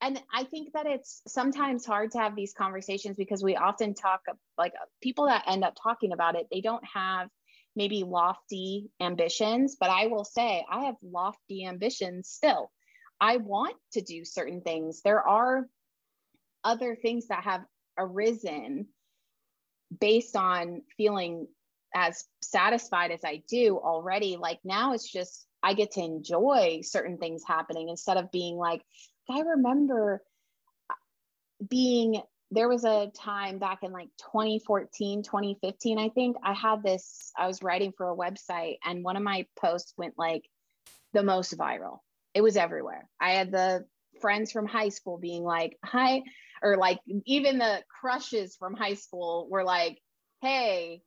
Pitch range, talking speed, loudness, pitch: 180-230 Hz, 155 wpm, -29 LUFS, 200 Hz